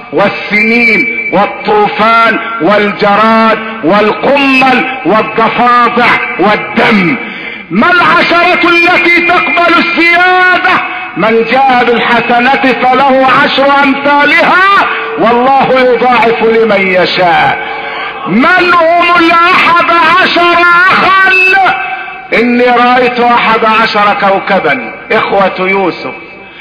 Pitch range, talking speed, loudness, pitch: 220-345 Hz, 75 wpm, -6 LUFS, 255 Hz